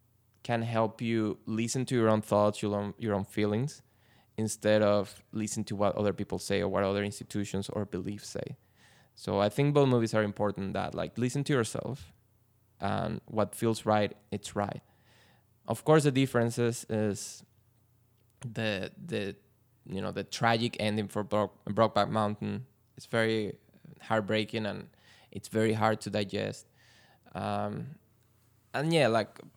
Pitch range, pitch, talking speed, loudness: 105-115 Hz, 110 Hz, 150 wpm, -31 LUFS